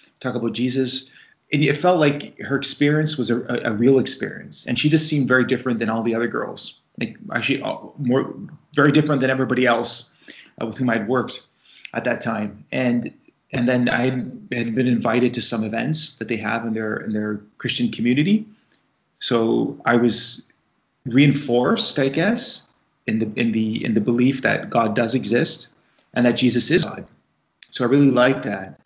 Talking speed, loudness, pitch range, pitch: 185 wpm, -20 LUFS, 120-140 Hz, 125 Hz